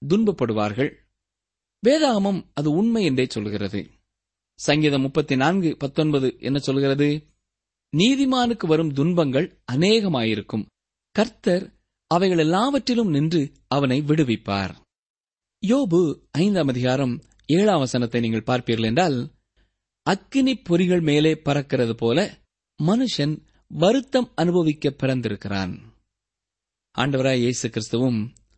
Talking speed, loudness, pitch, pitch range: 90 wpm, -22 LUFS, 140 Hz, 110-175 Hz